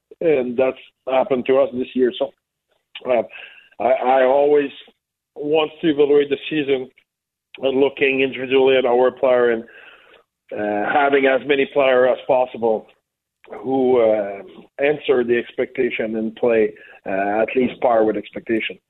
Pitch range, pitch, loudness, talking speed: 115-140 Hz, 130 Hz, -19 LUFS, 140 wpm